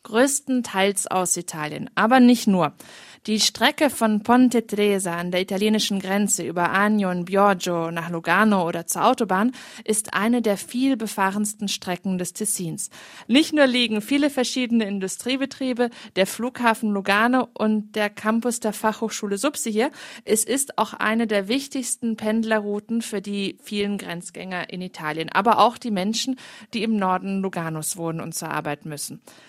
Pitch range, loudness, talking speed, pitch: 190-235 Hz, -22 LUFS, 150 wpm, 215 Hz